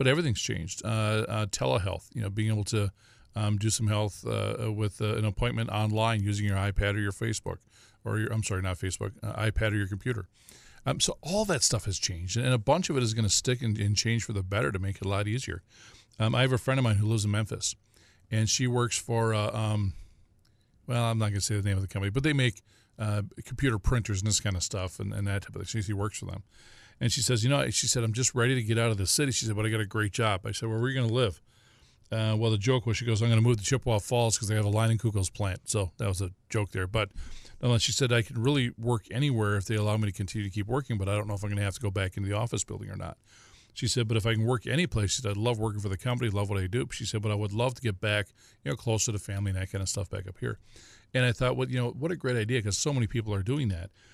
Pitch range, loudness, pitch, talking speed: 100-120 Hz, -29 LUFS, 110 Hz, 295 wpm